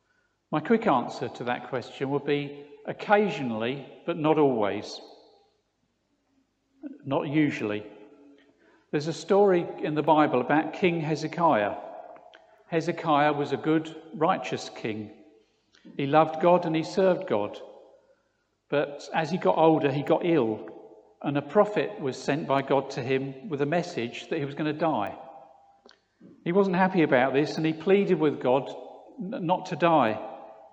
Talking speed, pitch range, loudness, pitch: 145 wpm, 140-185 Hz, -26 LUFS, 155 Hz